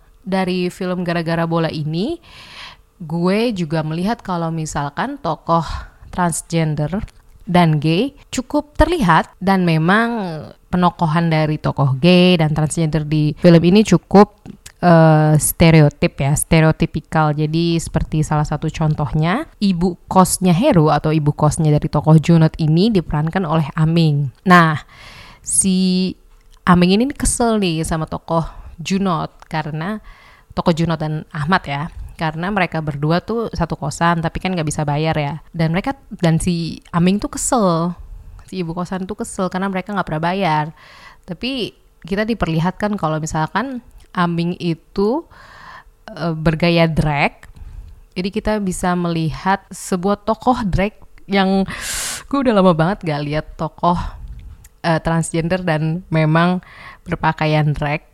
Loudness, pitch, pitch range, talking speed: -17 LUFS, 170 Hz, 155-185 Hz, 130 wpm